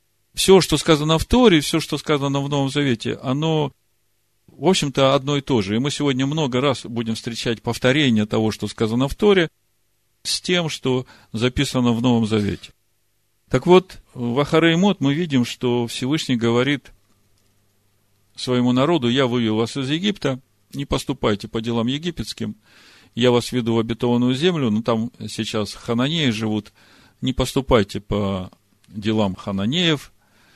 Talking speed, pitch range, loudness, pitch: 145 wpm, 110-140 Hz, -20 LUFS, 120 Hz